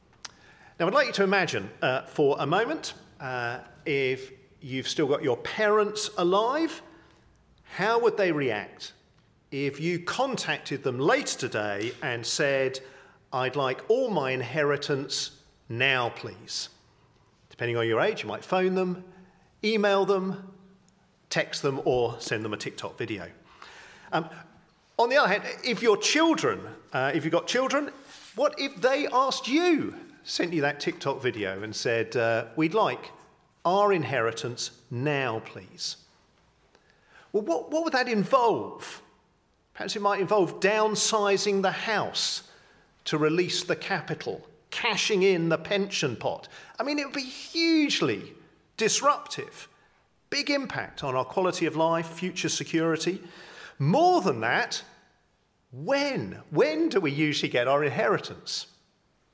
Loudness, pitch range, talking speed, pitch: -27 LUFS, 140-225 Hz, 140 wpm, 180 Hz